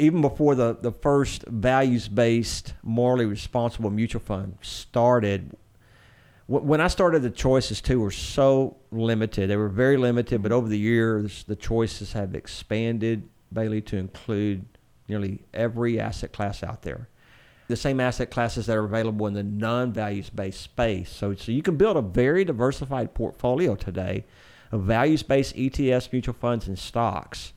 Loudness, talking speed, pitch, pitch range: -25 LUFS, 160 wpm, 115 Hz, 105-125 Hz